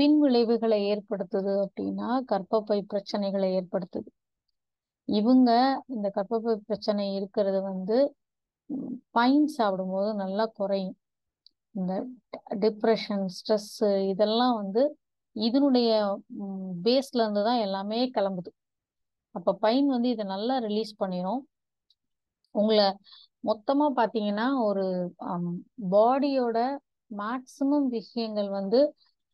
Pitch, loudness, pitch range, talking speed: 215 Hz, -27 LUFS, 200-245 Hz, 85 wpm